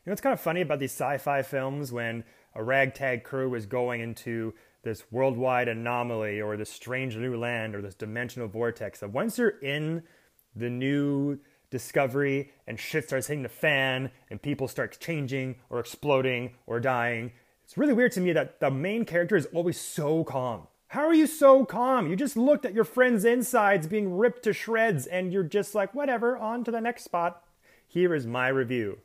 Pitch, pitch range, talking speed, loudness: 140 Hz, 120-195 Hz, 195 wpm, -28 LUFS